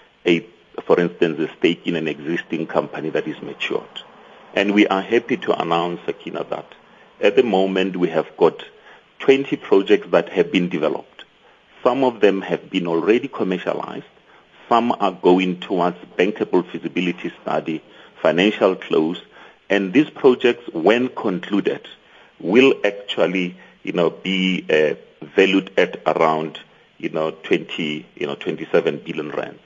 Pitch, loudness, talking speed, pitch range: 90 Hz, -20 LUFS, 140 wpm, 80-95 Hz